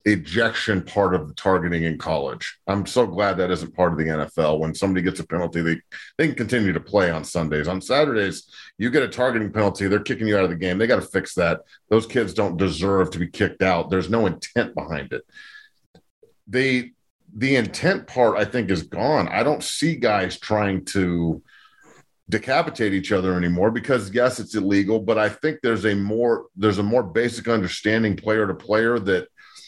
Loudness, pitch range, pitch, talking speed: -22 LUFS, 95-120 Hz, 105 Hz, 200 wpm